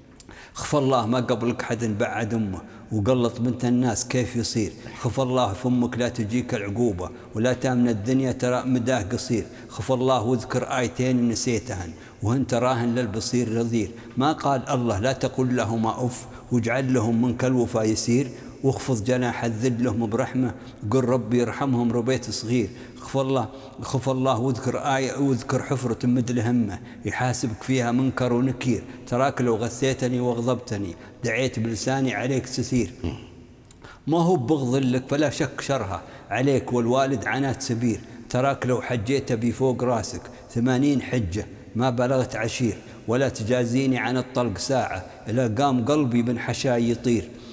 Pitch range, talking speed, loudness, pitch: 115-130 Hz, 140 wpm, -24 LUFS, 125 Hz